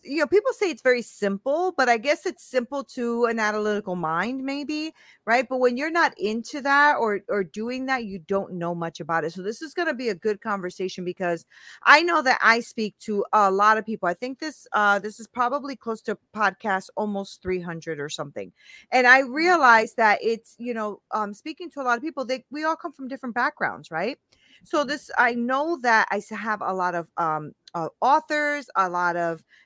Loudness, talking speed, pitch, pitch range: -23 LUFS, 215 wpm, 230 Hz, 200-280 Hz